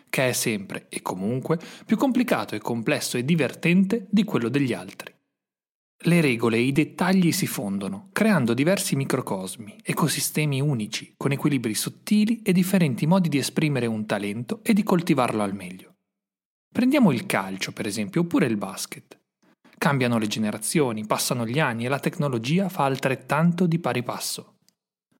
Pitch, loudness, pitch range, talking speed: 145 Hz, -24 LUFS, 115-185 Hz, 150 wpm